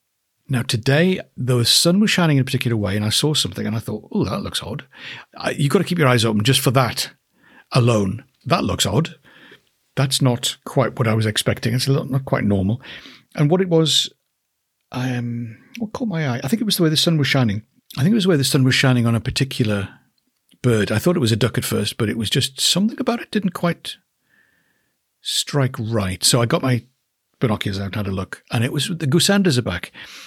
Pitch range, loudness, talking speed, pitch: 115-150 Hz, -19 LUFS, 230 wpm, 130 Hz